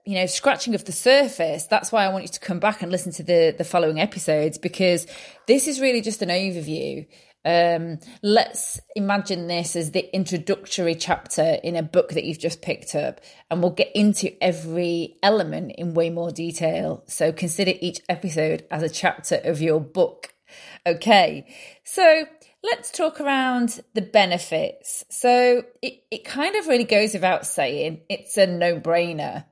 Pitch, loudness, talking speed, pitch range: 185 Hz, -22 LUFS, 170 wpm, 170-225 Hz